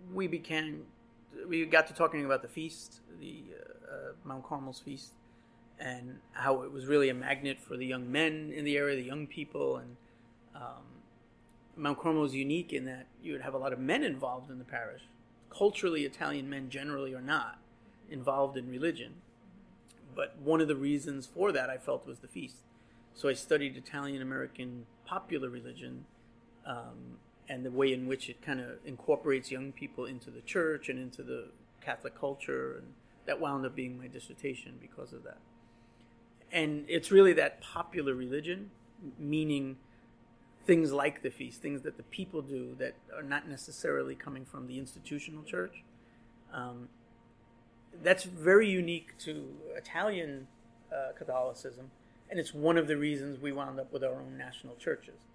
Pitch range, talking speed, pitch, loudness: 120-155 Hz, 170 wpm, 135 Hz, -34 LUFS